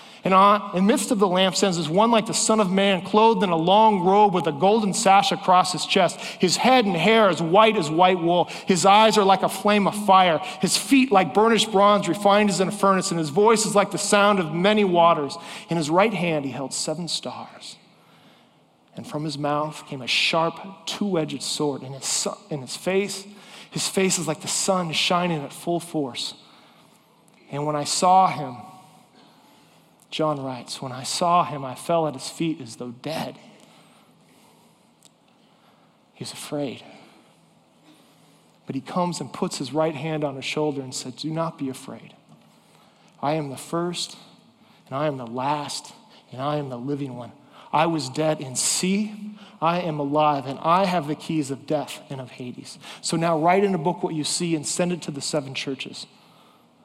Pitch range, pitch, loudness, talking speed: 150-195 Hz, 170 Hz, -22 LUFS, 190 wpm